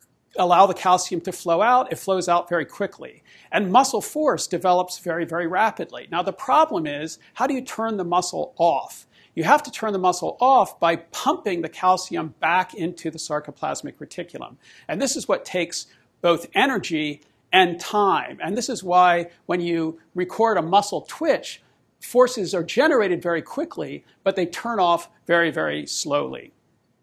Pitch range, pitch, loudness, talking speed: 170-220 Hz, 180 Hz, -22 LUFS, 170 wpm